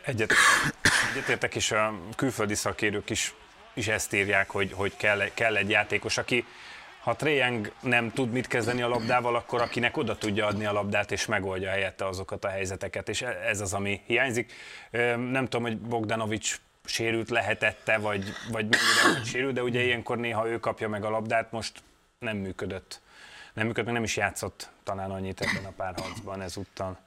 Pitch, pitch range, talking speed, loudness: 110 Hz, 100-120 Hz, 175 wpm, -27 LUFS